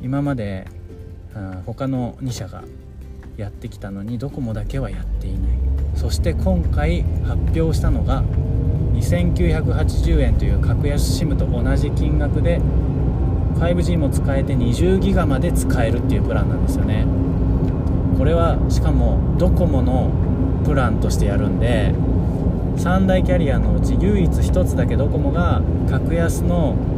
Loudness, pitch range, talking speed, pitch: -19 LUFS, 85-105 Hz, 260 characters per minute, 90 Hz